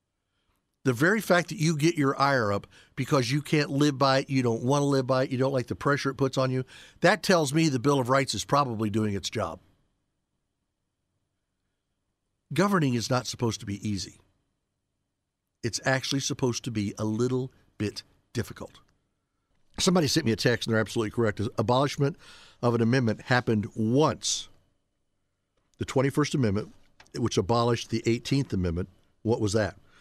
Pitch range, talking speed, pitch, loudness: 100-135 Hz, 170 wpm, 120 Hz, -27 LUFS